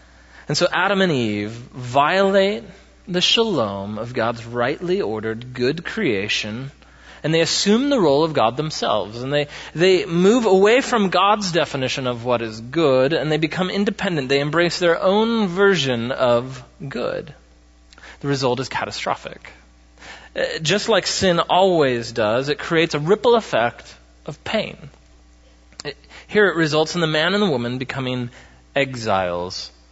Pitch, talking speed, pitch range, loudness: 140 Hz, 145 wpm, 115-185 Hz, -19 LUFS